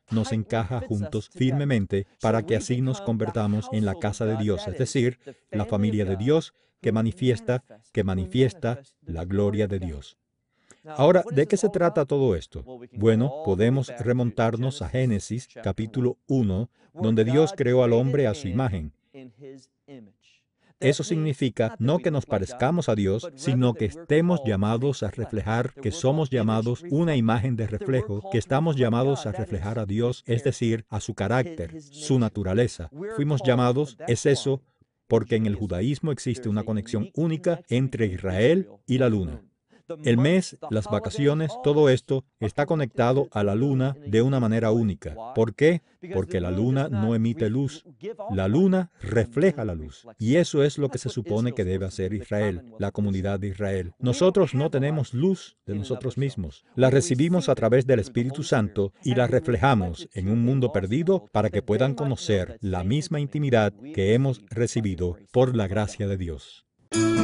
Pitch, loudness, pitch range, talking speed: 120 Hz, -25 LUFS, 105-135 Hz, 160 wpm